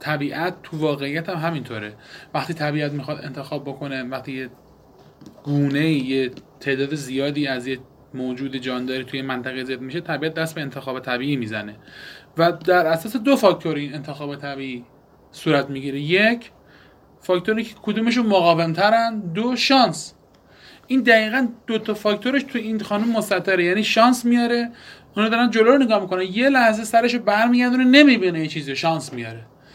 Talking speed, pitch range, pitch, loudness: 150 wpm, 135-220 Hz, 160 Hz, -20 LUFS